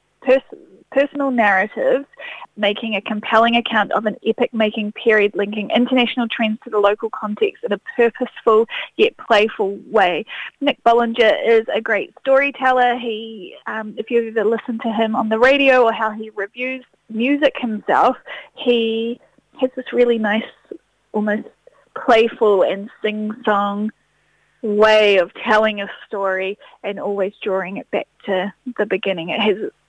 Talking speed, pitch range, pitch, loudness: 145 wpm, 210-250 Hz, 225 Hz, -18 LUFS